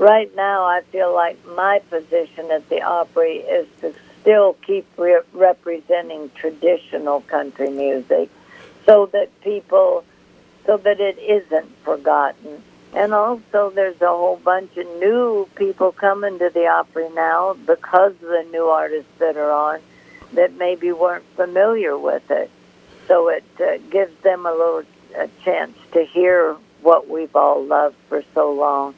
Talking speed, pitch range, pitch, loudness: 150 wpm, 160-205 Hz, 180 Hz, -18 LUFS